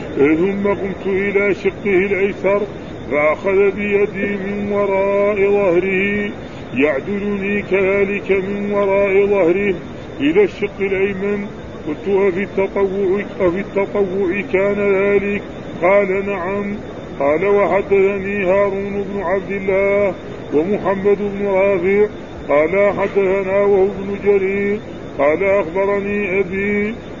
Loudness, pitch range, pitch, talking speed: -17 LUFS, 195-200 Hz, 200 Hz, 95 wpm